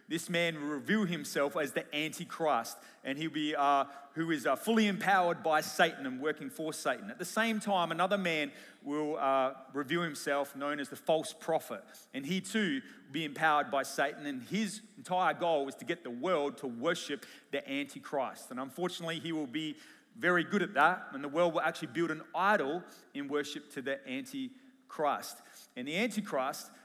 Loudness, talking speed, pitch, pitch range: -33 LUFS, 190 wpm, 165 Hz, 150-210 Hz